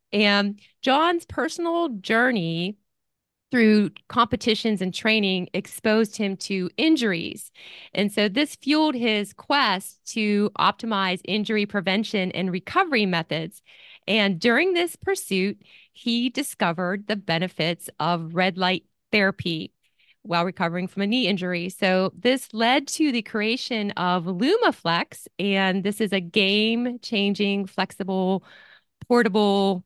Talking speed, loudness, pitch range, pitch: 120 wpm, -23 LUFS, 185-235 Hz, 205 Hz